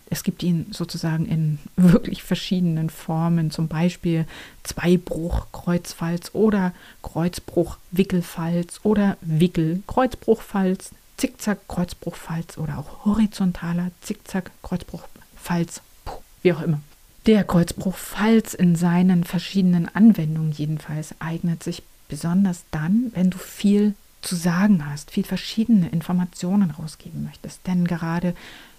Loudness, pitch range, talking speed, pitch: -22 LUFS, 165-195 Hz, 100 wpm, 175 Hz